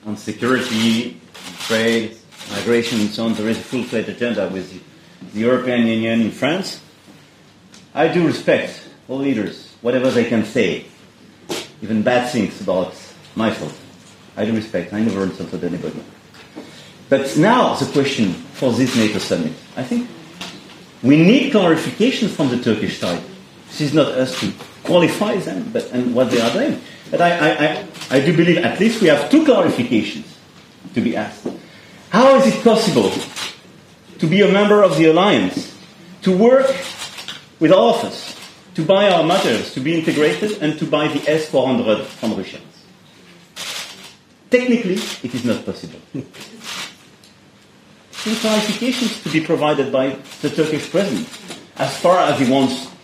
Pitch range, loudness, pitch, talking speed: 120-190 Hz, -17 LUFS, 150 Hz, 155 wpm